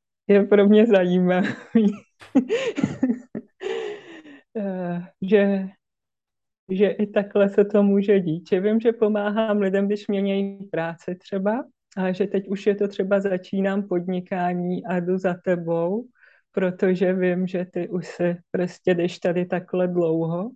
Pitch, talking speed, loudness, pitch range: 195 Hz, 130 wpm, -22 LUFS, 180-210 Hz